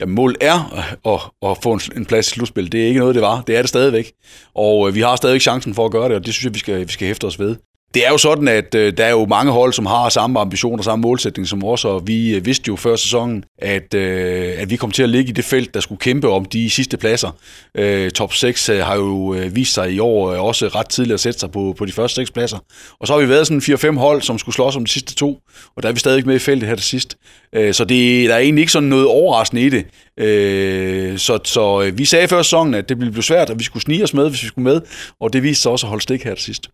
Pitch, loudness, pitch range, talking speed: 115 Hz, -15 LUFS, 100-130 Hz, 270 wpm